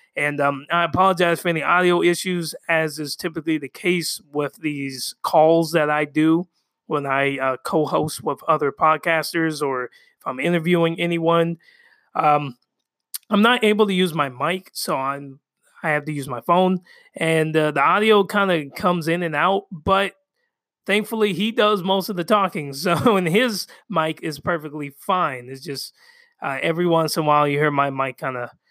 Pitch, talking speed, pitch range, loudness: 165 Hz, 180 wpm, 150-185 Hz, -20 LUFS